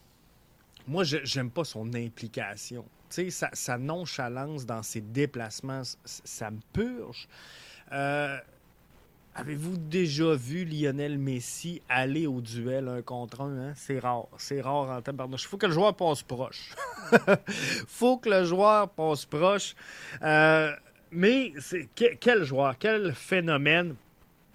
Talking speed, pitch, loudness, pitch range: 135 wpm, 140 Hz, -28 LUFS, 125-170 Hz